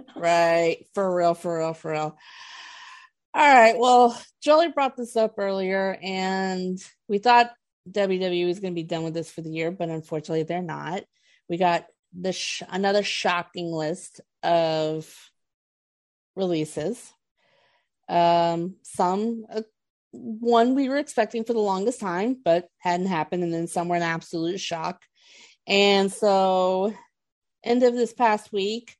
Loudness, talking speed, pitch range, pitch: -23 LUFS, 145 wpm, 170-225 Hz, 190 Hz